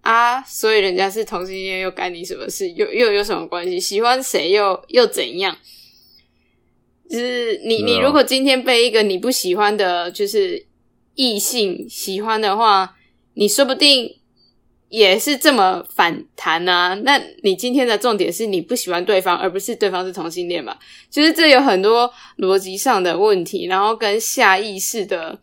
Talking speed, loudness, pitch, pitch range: 255 characters per minute, -17 LUFS, 230 Hz, 190-280 Hz